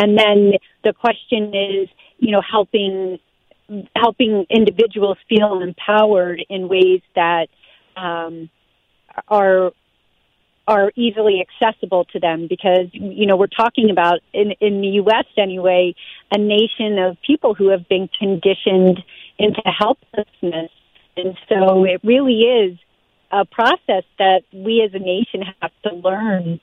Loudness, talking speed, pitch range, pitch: -17 LUFS, 130 wpm, 185-215 Hz, 195 Hz